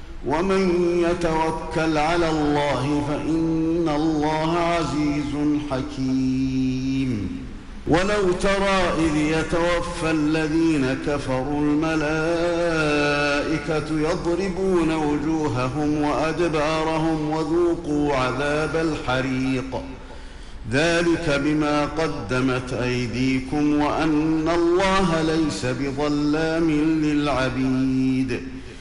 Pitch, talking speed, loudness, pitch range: 150 Hz, 60 wpm, -22 LUFS, 140-160 Hz